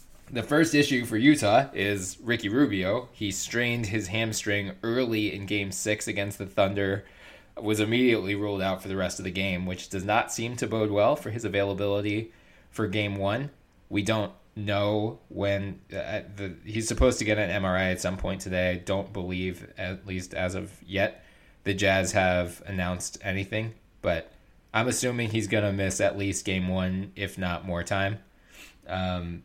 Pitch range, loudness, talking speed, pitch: 95-110 Hz, -28 LUFS, 175 wpm, 100 Hz